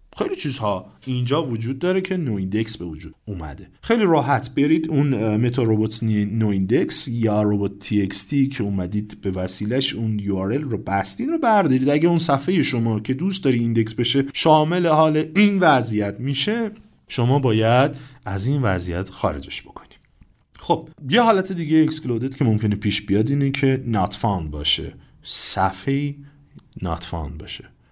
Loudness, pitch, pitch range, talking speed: -21 LUFS, 125 Hz, 105-150 Hz, 150 wpm